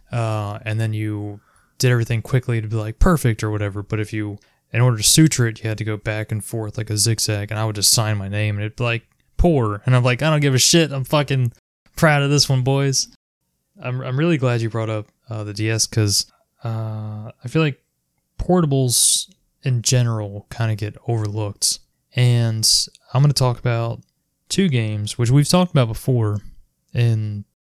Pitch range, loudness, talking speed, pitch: 105-130 Hz, -19 LUFS, 205 wpm, 115 Hz